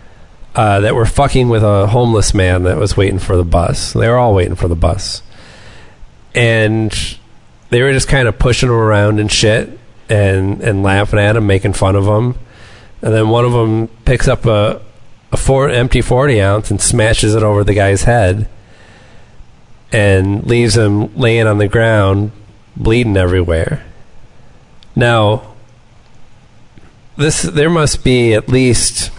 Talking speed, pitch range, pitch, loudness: 160 wpm, 100-120 Hz, 110 Hz, -12 LUFS